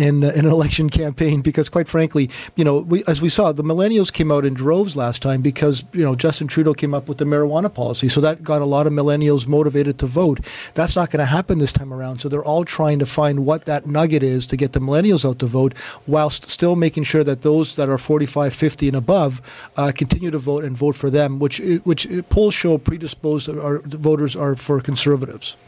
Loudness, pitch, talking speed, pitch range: -18 LUFS, 150 Hz, 230 wpm, 140-160 Hz